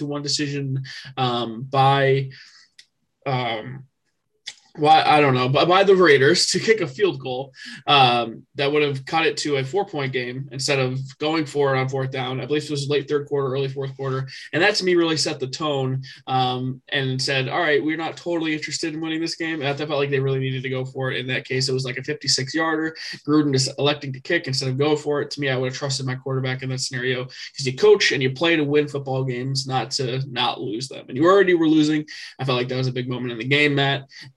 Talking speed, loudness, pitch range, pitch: 250 wpm, -21 LUFS, 130-150 Hz, 135 Hz